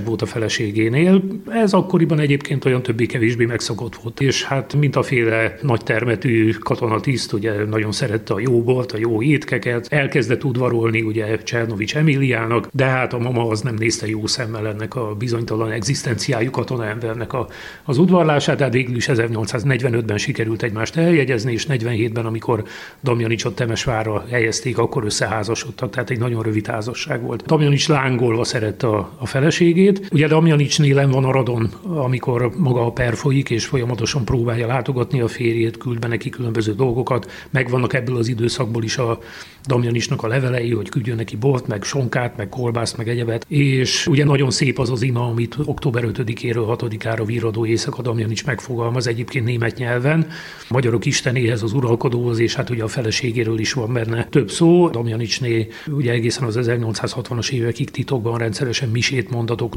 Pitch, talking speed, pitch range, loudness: 120 Hz, 160 wpm, 115-135 Hz, -19 LUFS